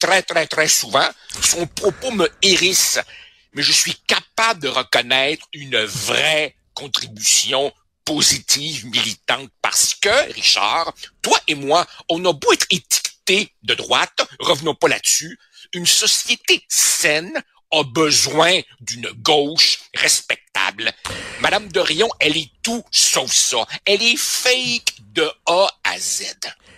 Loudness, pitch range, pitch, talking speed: -16 LUFS, 145-195 Hz, 165 Hz, 130 wpm